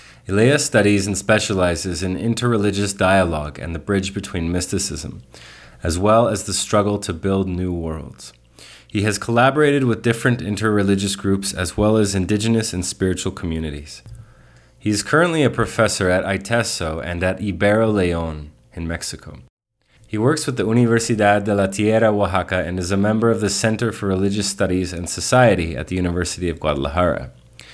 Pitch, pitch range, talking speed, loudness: 100 Hz, 90-110 Hz, 160 wpm, -19 LUFS